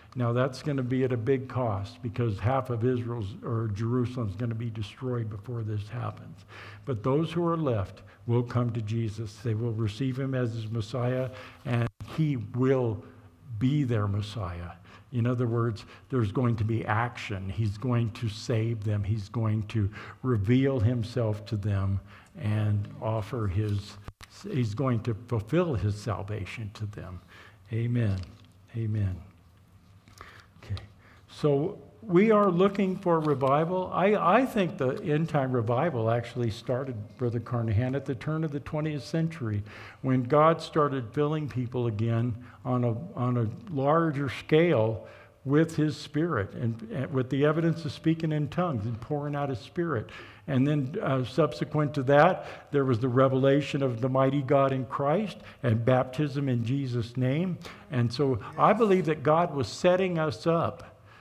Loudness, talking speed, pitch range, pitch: -28 LUFS, 160 wpm, 110-145 Hz, 120 Hz